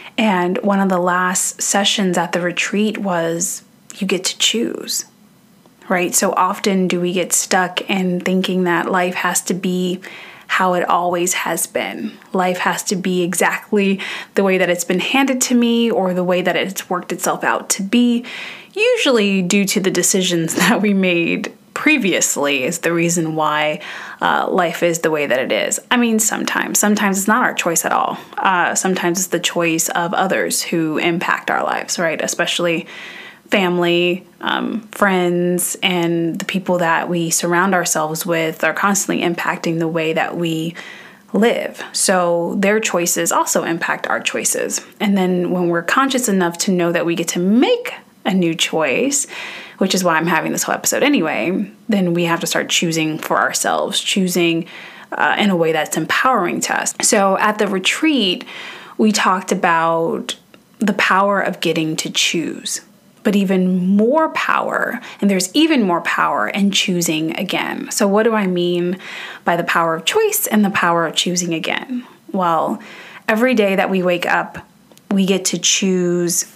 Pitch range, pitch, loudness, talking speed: 175-205 Hz, 185 Hz, -17 LUFS, 170 wpm